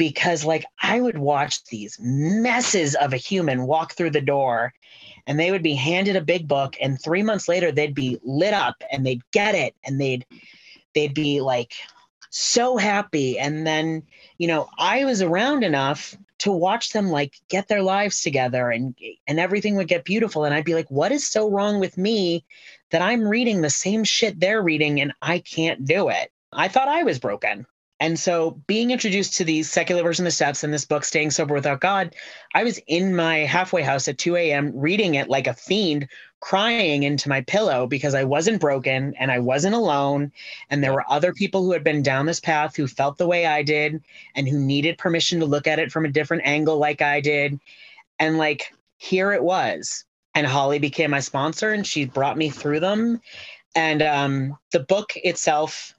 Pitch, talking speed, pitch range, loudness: 160 Hz, 200 wpm, 145-190 Hz, -21 LUFS